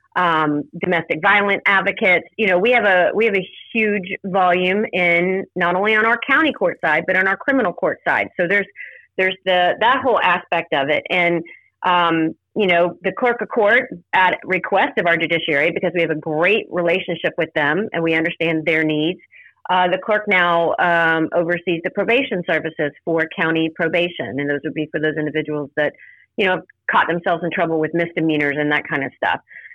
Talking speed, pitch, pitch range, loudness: 195 wpm, 175 Hz, 160-190 Hz, -18 LUFS